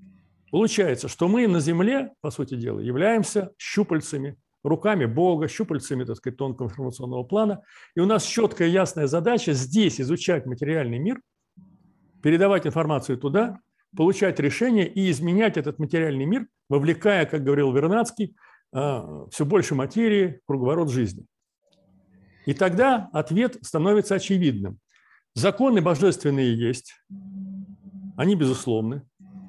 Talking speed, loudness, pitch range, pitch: 120 wpm, -23 LUFS, 135-200 Hz, 165 Hz